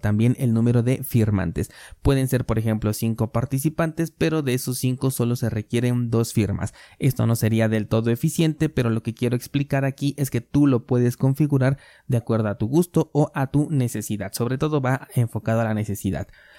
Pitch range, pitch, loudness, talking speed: 110-135 Hz, 120 Hz, -23 LUFS, 195 wpm